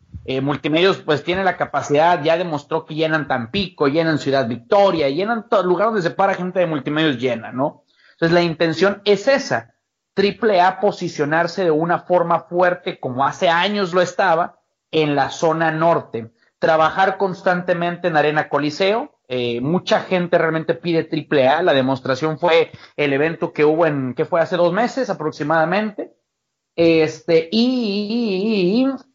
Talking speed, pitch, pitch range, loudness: 155 wpm, 165 Hz, 150-190 Hz, -18 LUFS